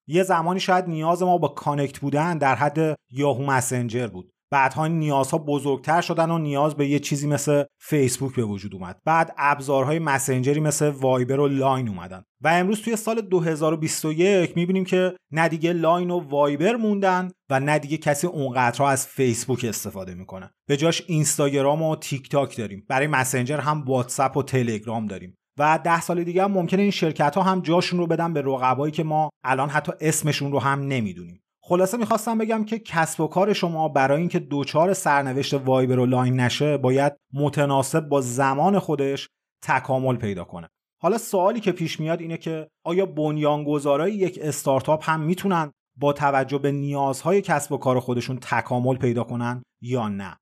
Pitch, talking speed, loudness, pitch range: 145 Hz, 170 wpm, -23 LUFS, 130-165 Hz